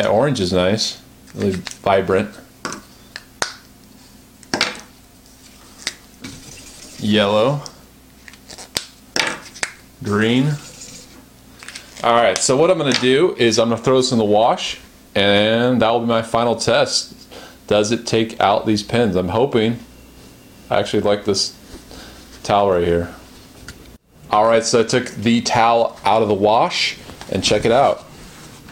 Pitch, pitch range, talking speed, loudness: 115 Hz, 105-120 Hz, 125 wpm, -17 LUFS